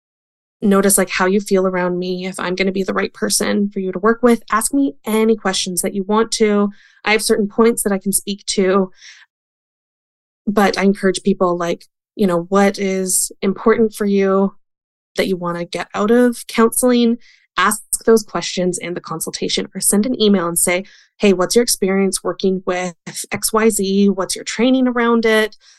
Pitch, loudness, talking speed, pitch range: 195 Hz, -16 LUFS, 190 wpm, 190-220 Hz